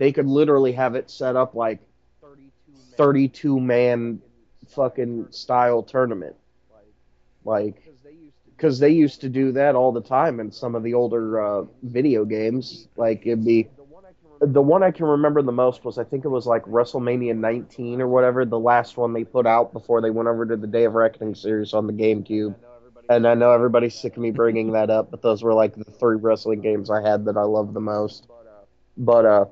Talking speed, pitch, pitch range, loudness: 205 wpm, 120 Hz, 110-130 Hz, -21 LUFS